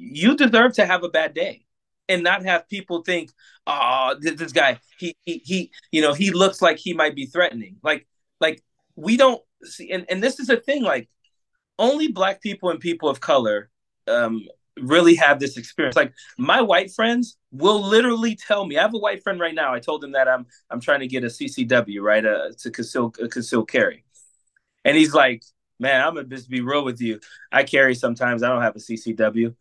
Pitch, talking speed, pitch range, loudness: 170 Hz, 205 wpm, 130-210 Hz, -20 LUFS